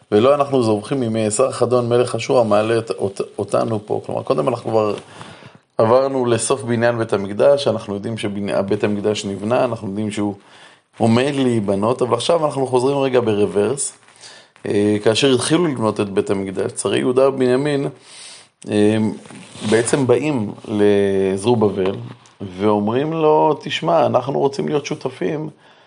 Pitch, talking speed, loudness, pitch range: 115 Hz, 135 wpm, -18 LUFS, 105-130 Hz